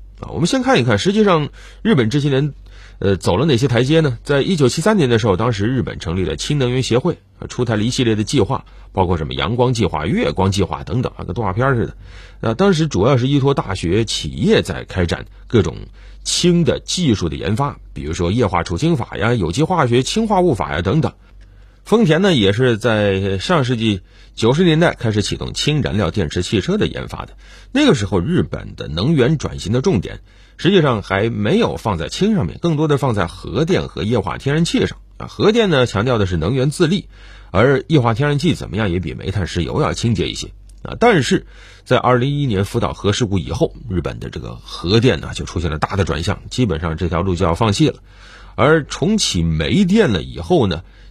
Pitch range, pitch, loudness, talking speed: 95-145 Hz, 115 Hz, -17 LUFS, 315 characters per minute